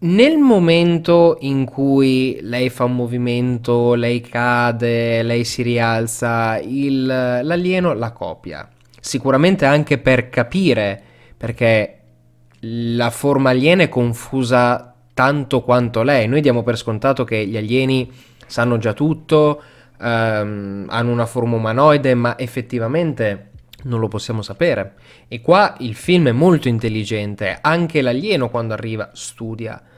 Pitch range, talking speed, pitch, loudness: 115-135 Hz, 125 wpm, 120 Hz, -17 LUFS